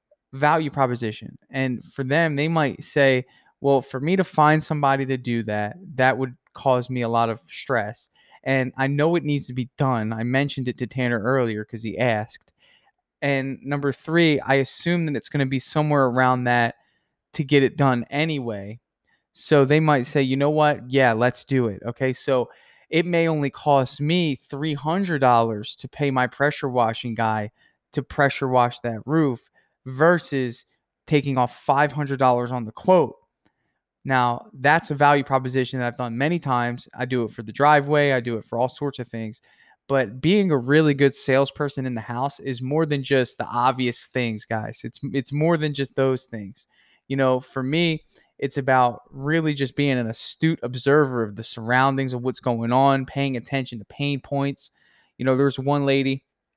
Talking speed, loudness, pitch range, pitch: 185 wpm, -22 LUFS, 125-145 Hz, 135 Hz